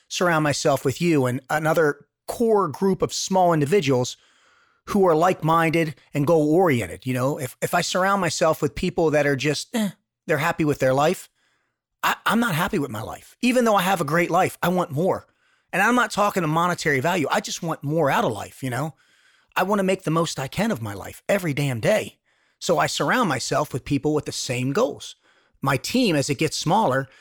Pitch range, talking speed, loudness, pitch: 140-185 Hz, 215 wpm, -22 LUFS, 160 Hz